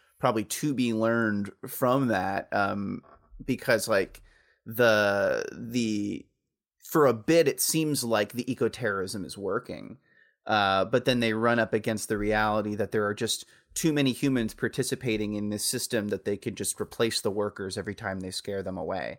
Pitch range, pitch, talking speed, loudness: 105-125 Hz, 110 Hz, 170 wpm, -27 LUFS